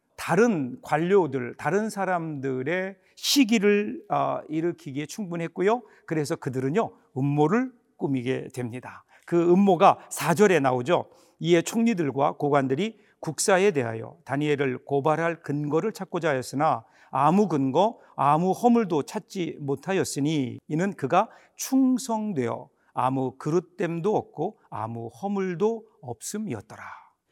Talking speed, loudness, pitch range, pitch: 275 characters per minute, -25 LUFS, 140-200 Hz, 165 Hz